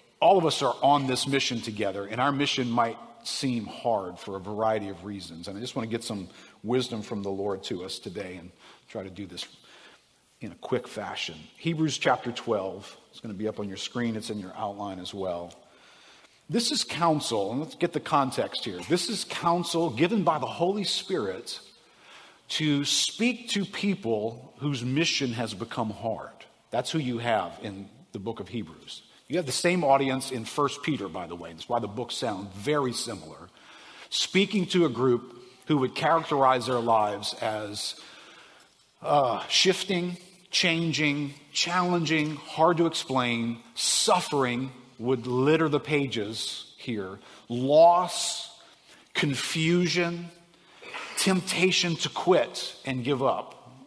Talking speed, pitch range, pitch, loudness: 160 wpm, 110-170 Hz, 135 Hz, -27 LUFS